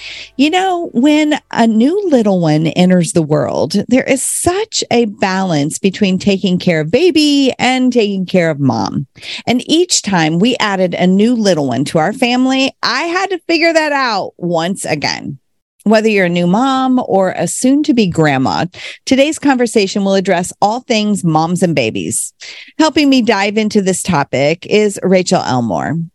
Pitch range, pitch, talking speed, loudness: 180-265 Hz, 205 Hz, 170 wpm, -13 LUFS